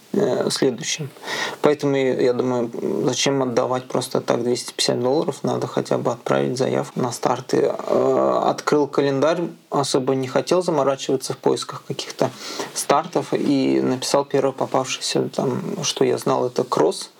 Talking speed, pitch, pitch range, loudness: 130 wpm, 135 Hz, 125-170 Hz, -21 LUFS